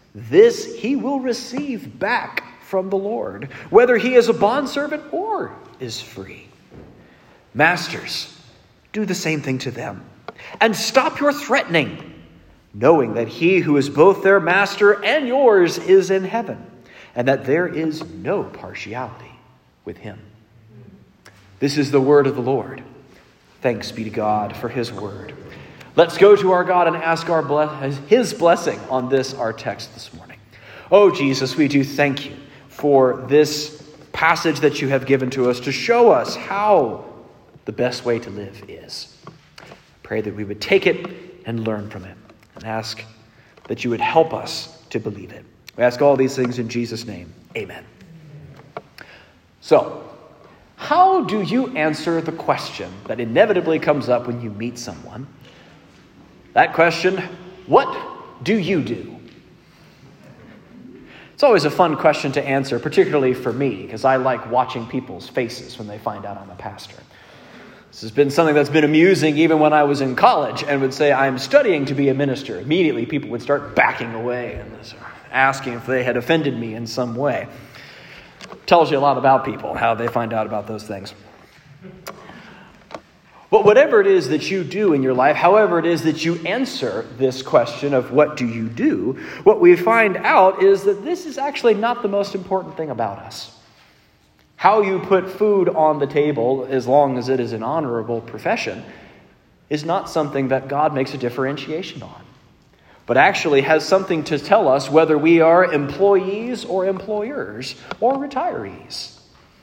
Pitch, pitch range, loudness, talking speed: 145 Hz, 120-185 Hz, -18 LUFS, 170 wpm